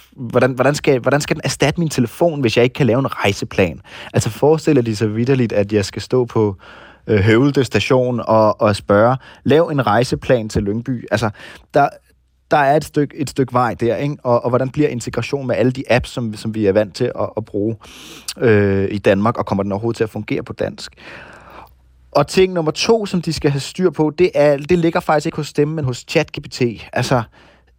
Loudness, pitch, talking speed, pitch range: -17 LUFS, 125 Hz, 220 wpm, 110-145 Hz